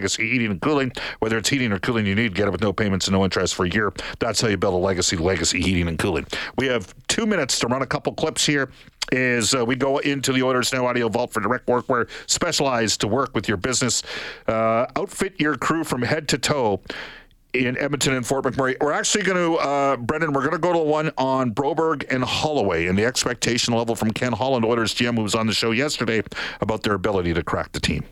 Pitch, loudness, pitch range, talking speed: 125 Hz, -22 LUFS, 110-140 Hz, 240 wpm